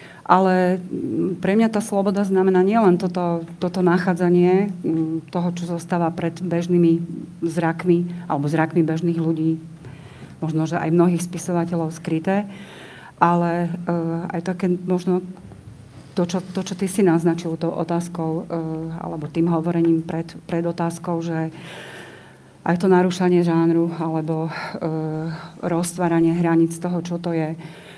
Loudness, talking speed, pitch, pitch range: -21 LUFS, 130 wpm, 170 Hz, 165-180 Hz